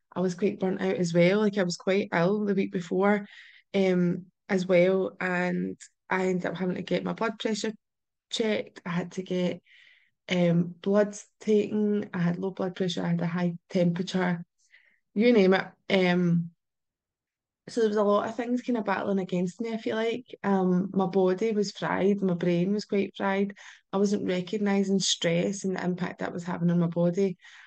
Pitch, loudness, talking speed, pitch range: 190 Hz, -27 LUFS, 190 wpm, 180-205 Hz